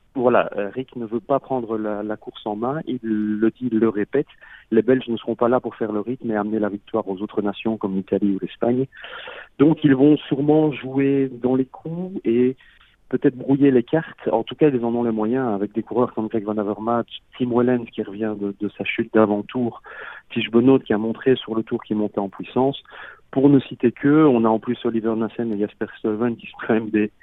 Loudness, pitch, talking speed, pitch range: -21 LUFS, 115 Hz, 230 wpm, 110-130 Hz